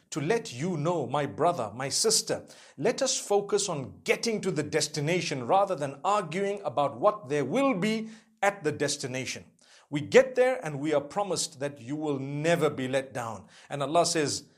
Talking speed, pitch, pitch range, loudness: 180 wpm, 155 Hz, 145-200 Hz, -28 LUFS